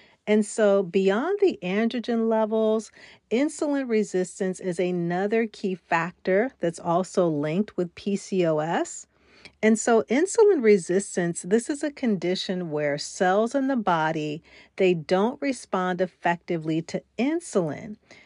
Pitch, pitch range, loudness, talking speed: 200 Hz, 180-225 Hz, -25 LUFS, 120 wpm